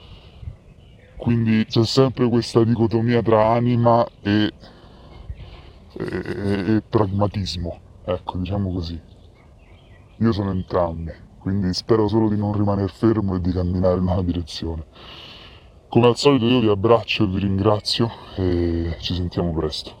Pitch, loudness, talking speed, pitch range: 100 Hz, -20 LUFS, 130 wpm, 90-115 Hz